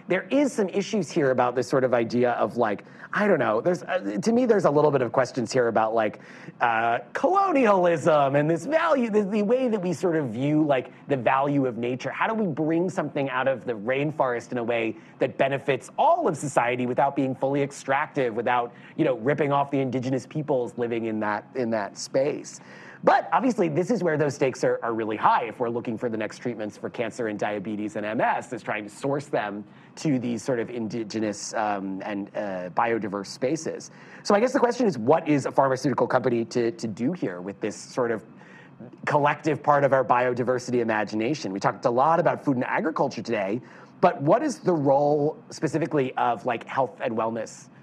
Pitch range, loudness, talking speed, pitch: 120-160 Hz, -25 LUFS, 205 wpm, 135 Hz